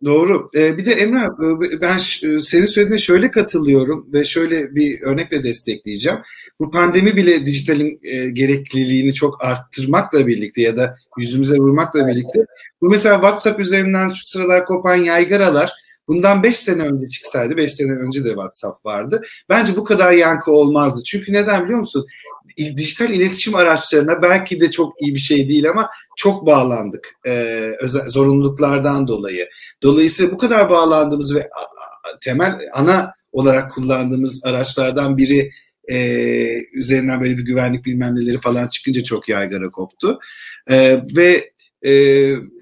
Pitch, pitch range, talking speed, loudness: 145 Hz, 130-180 Hz, 145 wpm, -15 LUFS